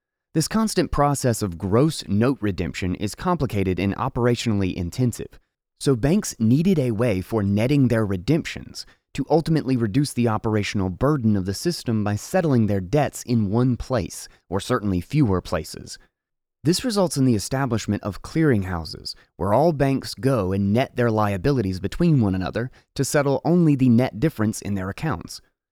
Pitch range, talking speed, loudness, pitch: 100-140 Hz, 160 wpm, -22 LUFS, 120 Hz